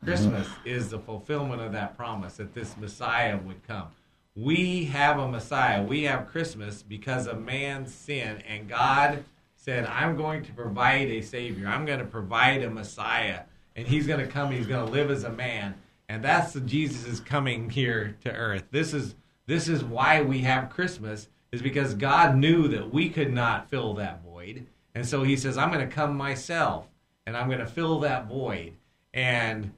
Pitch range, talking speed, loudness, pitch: 110-145 Hz, 200 wpm, -27 LUFS, 125 Hz